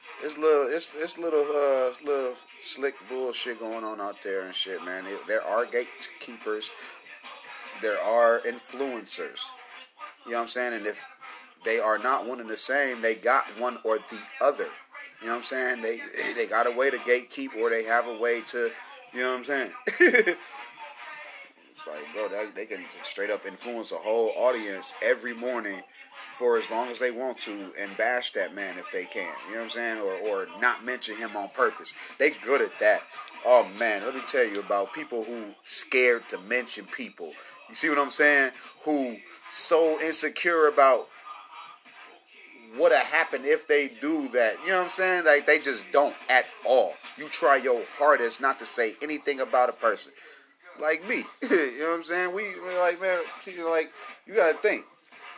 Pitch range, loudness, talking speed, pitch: 120-200 Hz, -26 LUFS, 190 wpm, 145 Hz